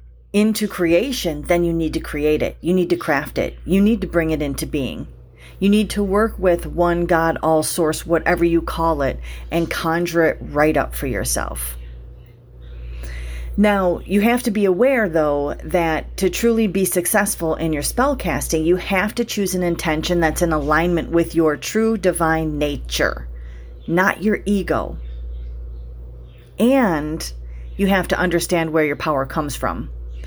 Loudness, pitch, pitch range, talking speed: -19 LUFS, 165 Hz, 145-185 Hz, 165 wpm